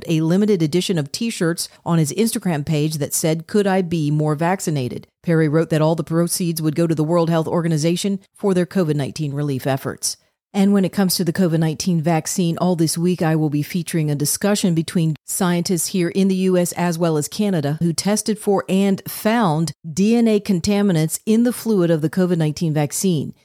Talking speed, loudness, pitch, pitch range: 200 wpm, -19 LUFS, 170 Hz, 155-190 Hz